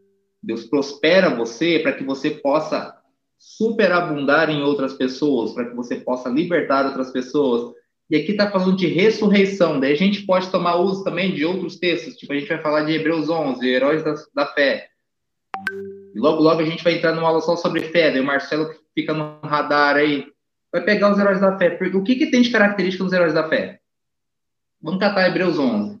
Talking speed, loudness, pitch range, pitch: 205 wpm, -19 LUFS, 145-190 Hz, 165 Hz